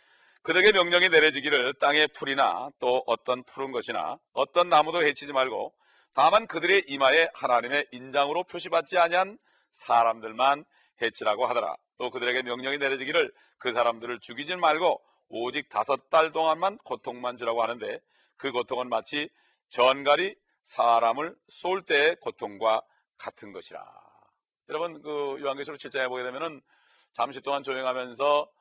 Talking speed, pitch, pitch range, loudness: 330 characters per minute, 140 Hz, 125-165 Hz, -26 LUFS